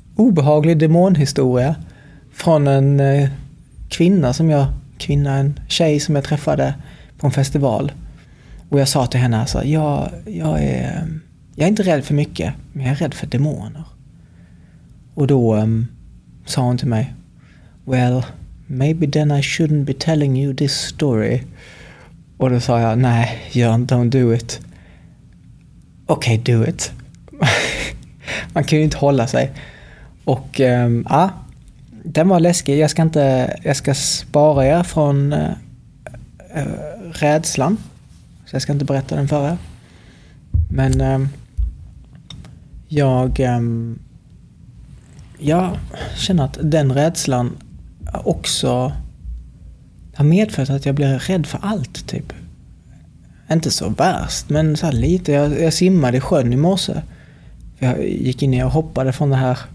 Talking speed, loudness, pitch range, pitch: 140 wpm, -17 LUFS, 125-155 Hz, 140 Hz